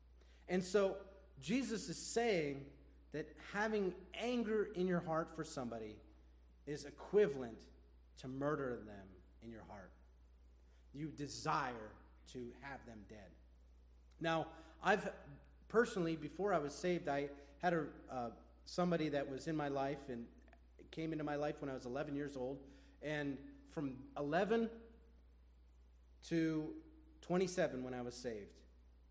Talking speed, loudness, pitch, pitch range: 130 wpm, -41 LUFS, 140 Hz, 105-165 Hz